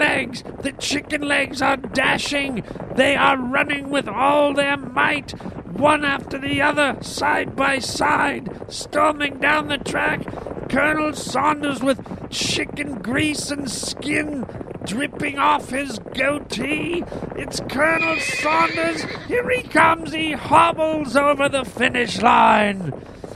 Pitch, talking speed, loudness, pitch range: 285 Hz, 120 wpm, -20 LUFS, 270-300 Hz